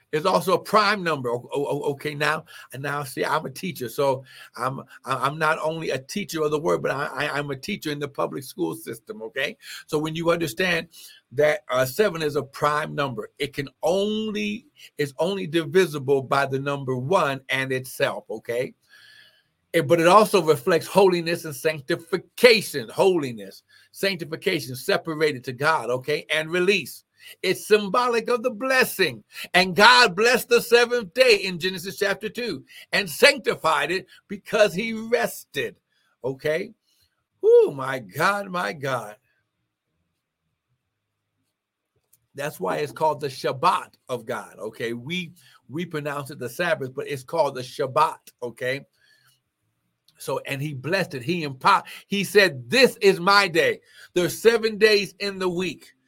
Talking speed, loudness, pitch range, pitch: 150 wpm, -23 LUFS, 140-200 Hz, 165 Hz